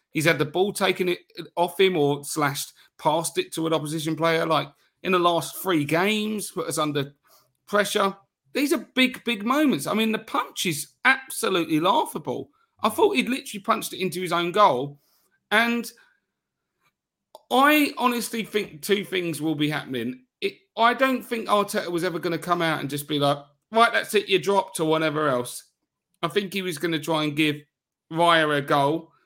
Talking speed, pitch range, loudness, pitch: 190 wpm, 155-220 Hz, -24 LUFS, 175 Hz